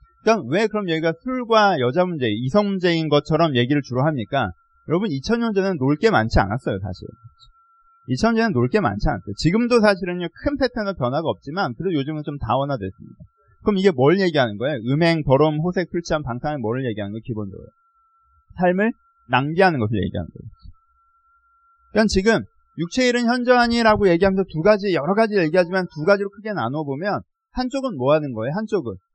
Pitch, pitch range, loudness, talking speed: 195 Hz, 150-235 Hz, -20 LUFS, 405 characters per minute